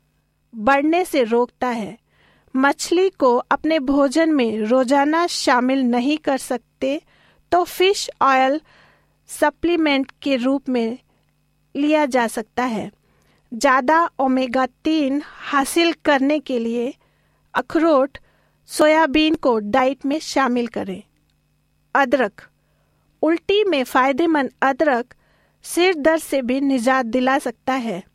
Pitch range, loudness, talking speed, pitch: 250-310 Hz, -19 LUFS, 110 wpm, 275 Hz